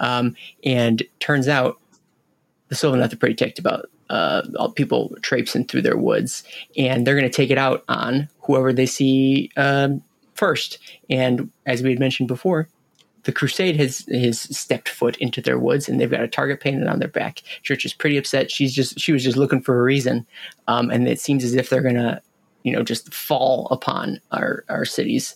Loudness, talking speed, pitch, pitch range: -21 LUFS, 200 wpm, 130 Hz, 125-140 Hz